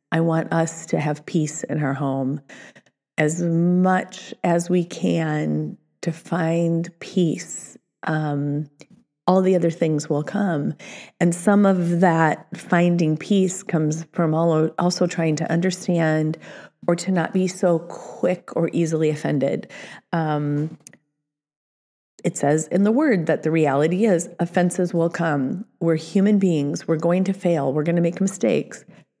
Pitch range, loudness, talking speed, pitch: 155-180 Hz, -21 LUFS, 145 wpm, 165 Hz